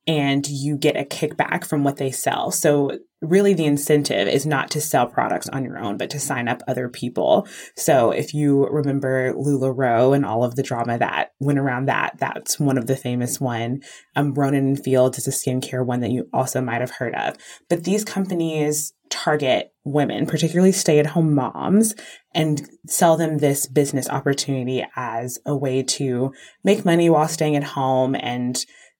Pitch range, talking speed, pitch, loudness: 130-150 Hz, 175 wpm, 140 Hz, -21 LUFS